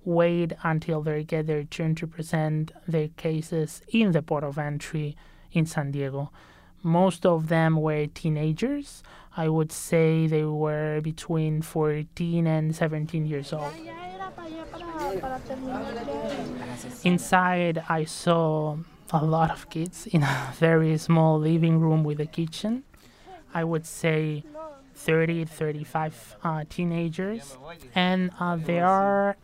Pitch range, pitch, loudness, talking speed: 155-175 Hz, 160 Hz, -26 LUFS, 125 wpm